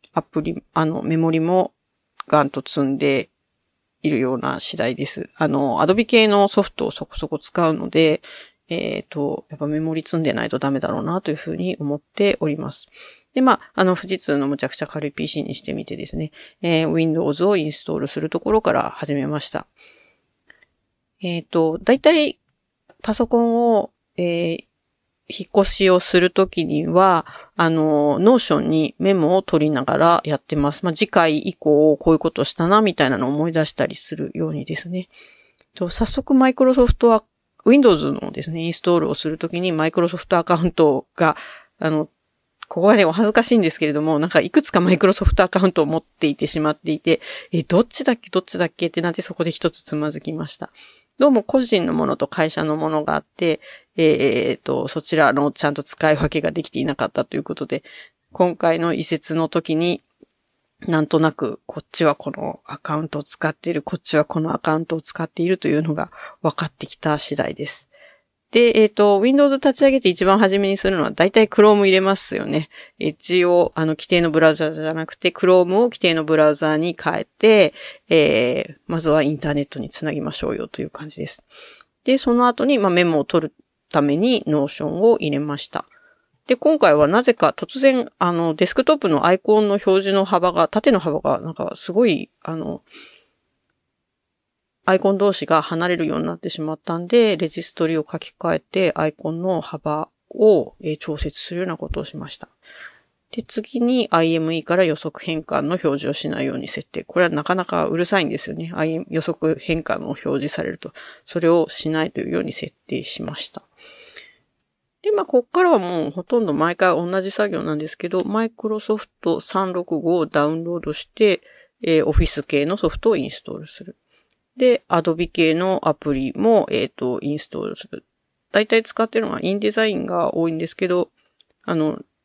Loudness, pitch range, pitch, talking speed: -19 LUFS, 155-200 Hz, 170 Hz, 390 characters per minute